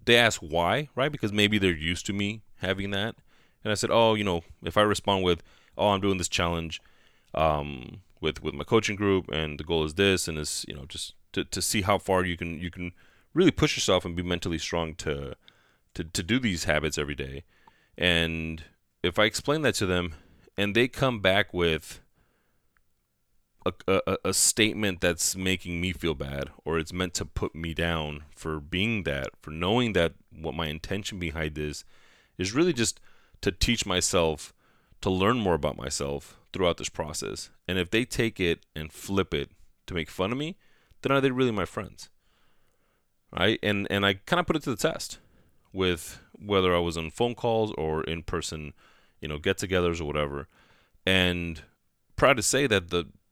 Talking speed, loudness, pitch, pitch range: 195 wpm, -27 LUFS, 90 Hz, 80-100 Hz